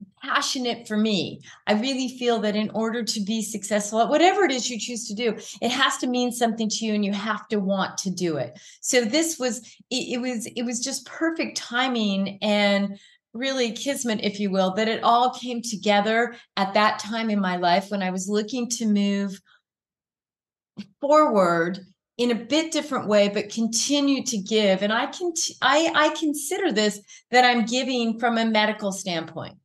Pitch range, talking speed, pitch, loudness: 205-250 Hz, 190 wpm, 225 Hz, -23 LUFS